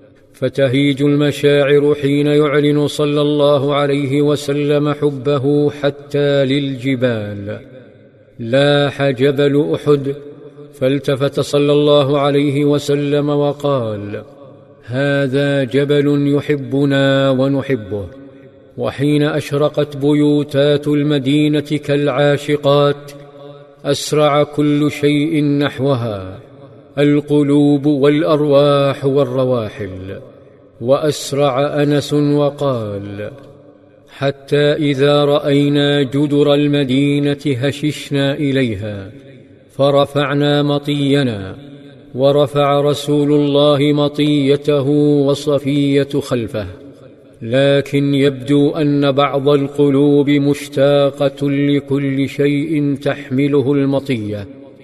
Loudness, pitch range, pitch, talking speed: -15 LUFS, 140-145 Hz, 140 Hz, 70 wpm